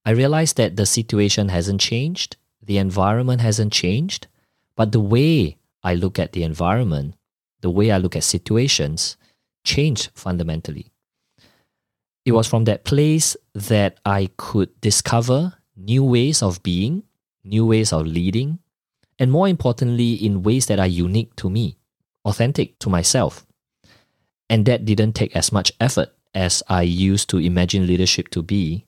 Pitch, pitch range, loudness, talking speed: 105 Hz, 95-120 Hz, -19 LUFS, 150 wpm